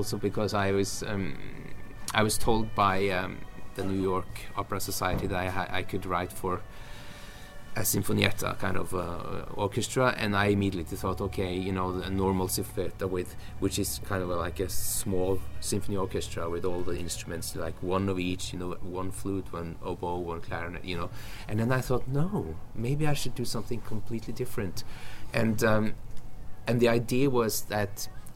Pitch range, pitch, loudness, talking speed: 90-110 Hz, 100 Hz, -31 LUFS, 180 wpm